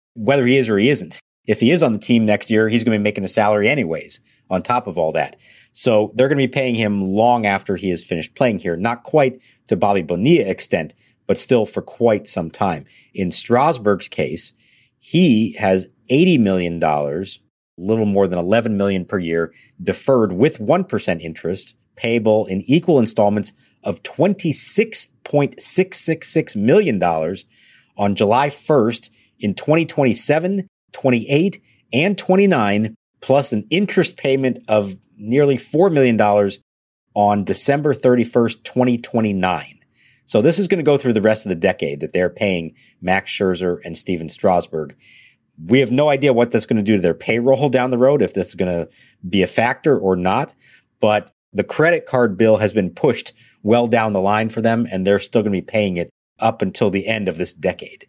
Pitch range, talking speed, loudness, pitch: 100-135 Hz, 180 wpm, -18 LUFS, 110 Hz